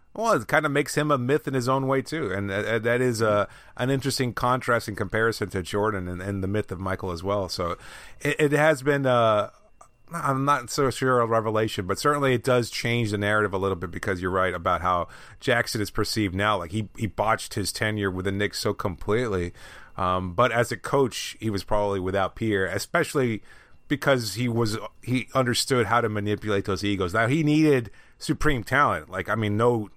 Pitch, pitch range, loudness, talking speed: 110 Hz, 100-130 Hz, -25 LUFS, 210 wpm